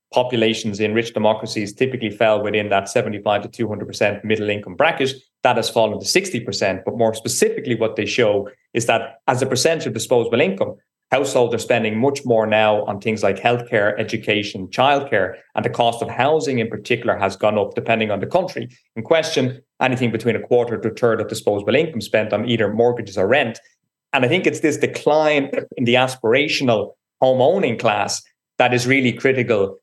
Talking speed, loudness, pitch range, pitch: 185 wpm, -19 LUFS, 110-130 Hz, 115 Hz